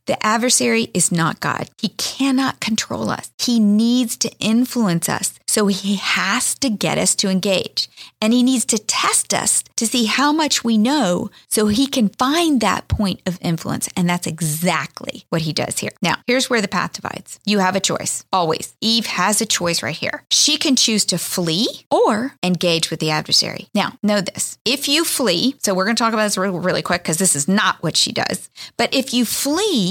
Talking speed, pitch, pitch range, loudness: 205 wpm, 215 Hz, 185-245 Hz, -18 LUFS